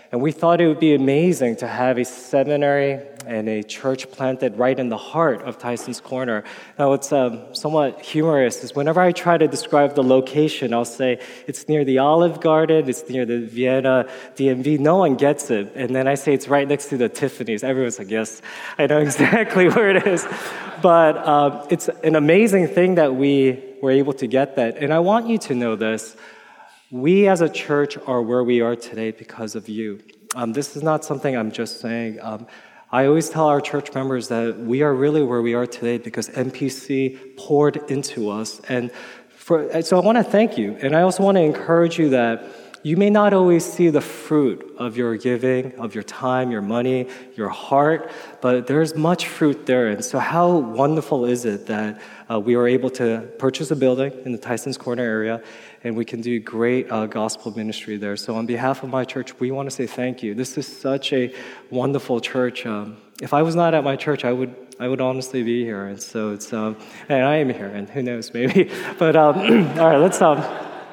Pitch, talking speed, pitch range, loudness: 130 Hz, 210 wpm, 120-150 Hz, -20 LUFS